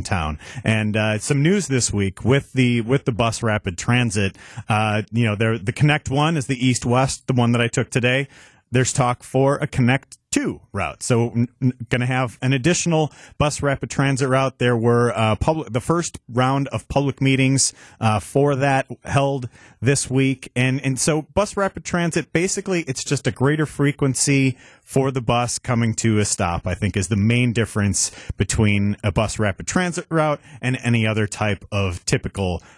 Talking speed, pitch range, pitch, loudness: 185 wpm, 110-140 Hz, 125 Hz, -20 LUFS